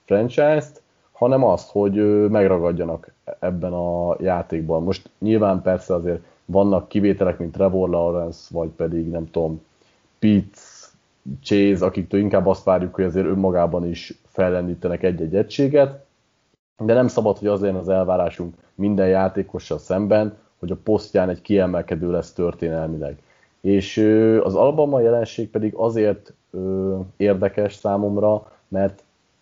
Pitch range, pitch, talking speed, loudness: 85-105 Hz, 95 Hz, 125 wpm, -20 LUFS